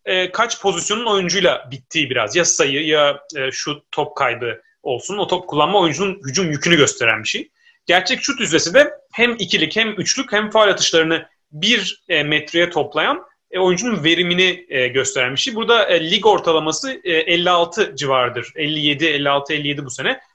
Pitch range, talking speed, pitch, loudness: 150-210 Hz, 145 wpm, 170 Hz, -17 LUFS